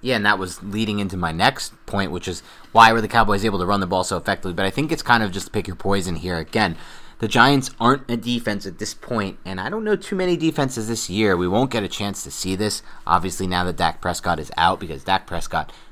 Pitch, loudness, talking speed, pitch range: 100 Hz, -21 LUFS, 260 wpm, 95-115 Hz